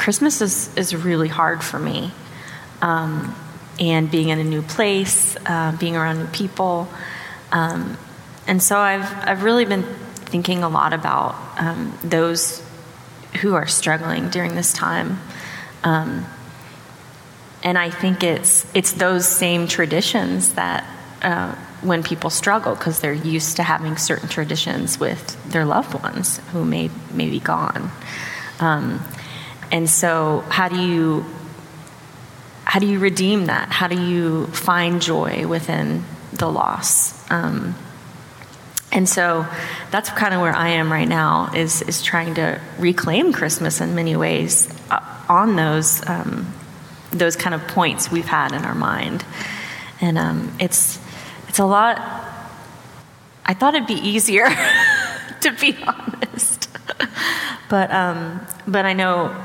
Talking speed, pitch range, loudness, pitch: 140 wpm, 160-190 Hz, -19 LUFS, 170 Hz